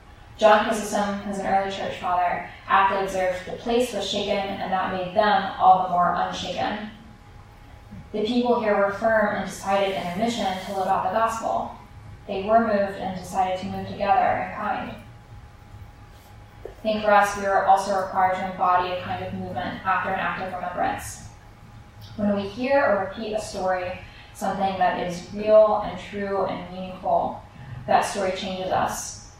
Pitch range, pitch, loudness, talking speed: 175-205 Hz, 195 Hz, -24 LUFS, 170 wpm